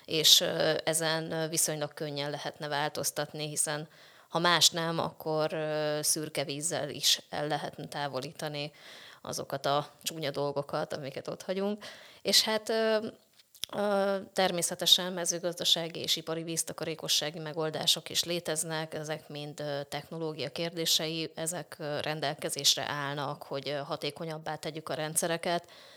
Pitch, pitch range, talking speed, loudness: 155 Hz, 150-170 Hz, 105 wpm, -30 LUFS